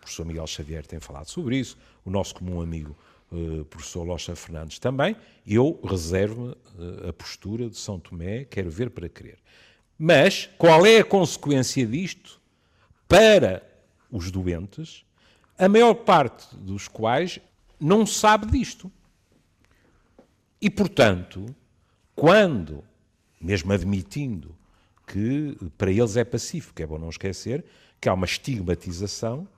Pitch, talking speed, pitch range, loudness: 100 Hz, 130 wpm, 90-130 Hz, -22 LUFS